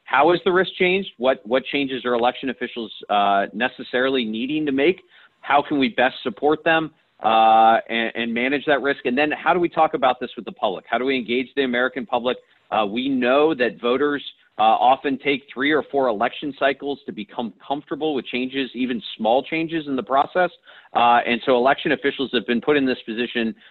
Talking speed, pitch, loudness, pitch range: 205 wpm, 130 Hz, -21 LUFS, 120-150 Hz